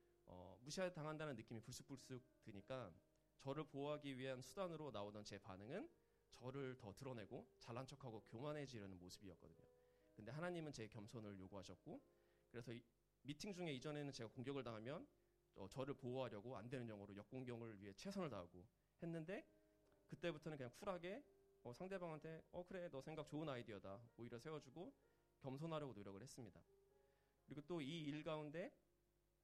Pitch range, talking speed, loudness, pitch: 105-155 Hz, 370 characters per minute, -54 LUFS, 130 Hz